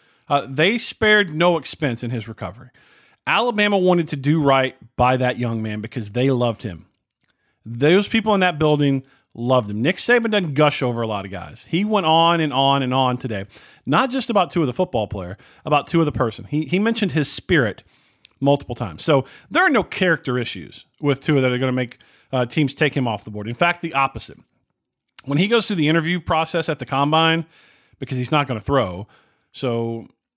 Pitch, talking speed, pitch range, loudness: 140 Hz, 210 wpm, 120-165 Hz, -20 LUFS